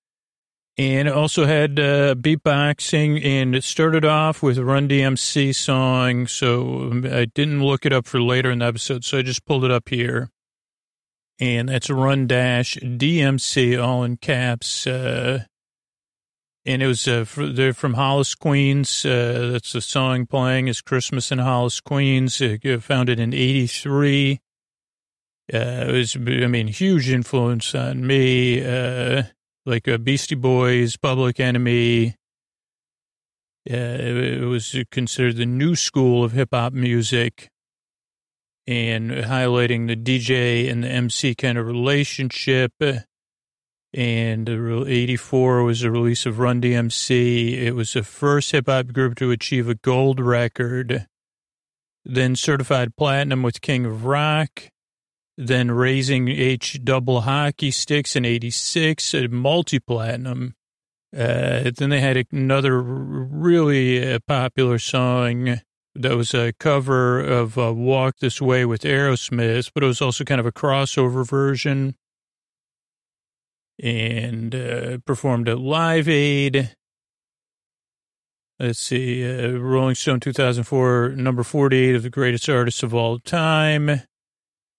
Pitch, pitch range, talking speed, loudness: 130 Hz, 120-135 Hz, 135 wpm, -20 LUFS